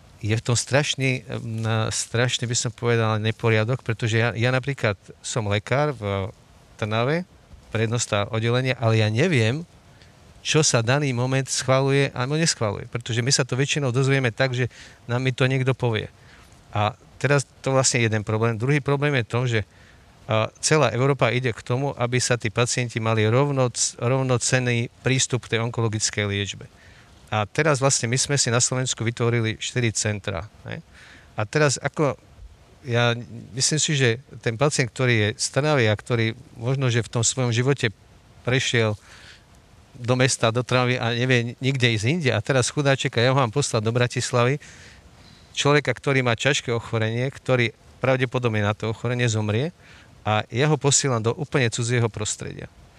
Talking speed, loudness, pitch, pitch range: 155 wpm, -22 LUFS, 120 Hz, 110-130 Hz